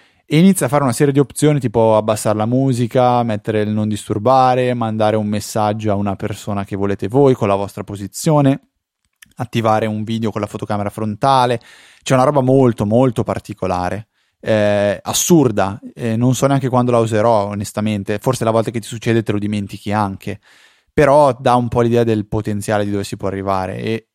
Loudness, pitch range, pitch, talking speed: -16 LUFS, 105-125 Hz, 110 Hz, 185 wpm